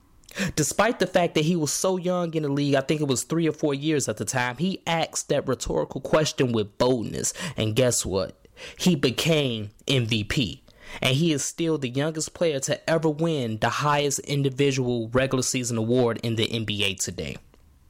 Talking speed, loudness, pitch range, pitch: 185 wpm, -24 LUFS, 115-155 Hz, 135 Hz